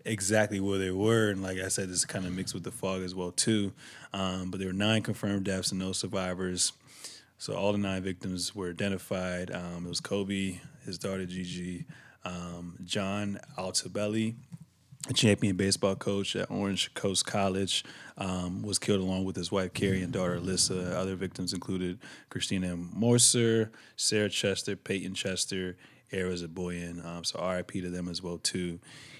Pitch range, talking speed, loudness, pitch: 90-100 Hz, 175 wpm, -31 LUFS, 95 Hz